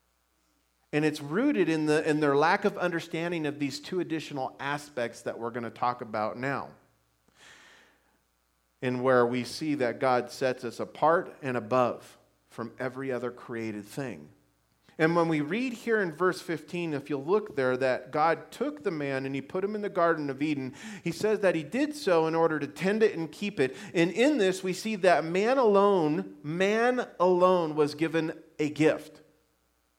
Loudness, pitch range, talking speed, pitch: -28 LUFS, 125-180 Hz, 185 wpm, 150 Hz